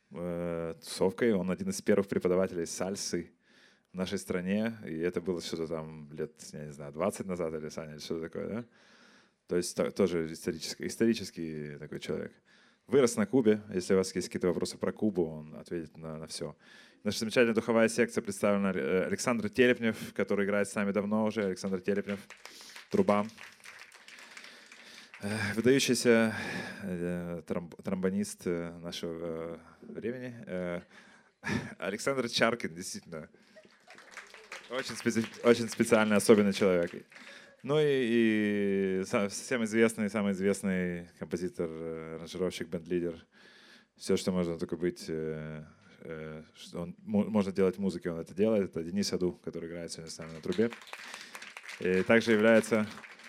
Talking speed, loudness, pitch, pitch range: 130 wpm, -31 LUFS, 95 Hz, 85-110 Hz